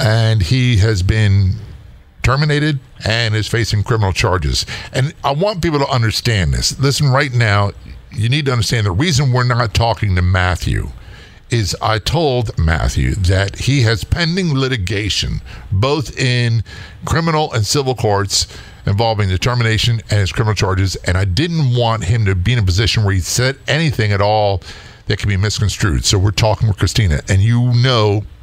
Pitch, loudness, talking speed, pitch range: 110 Hz, -15 LUFS, 170 wpm, 100-125 Hz